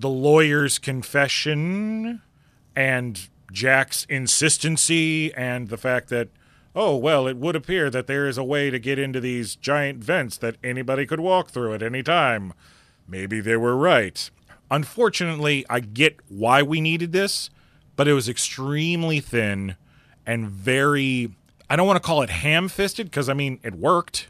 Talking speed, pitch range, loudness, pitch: 160 wpm, 125-155 Hz, -22 LUFS, 140 Hz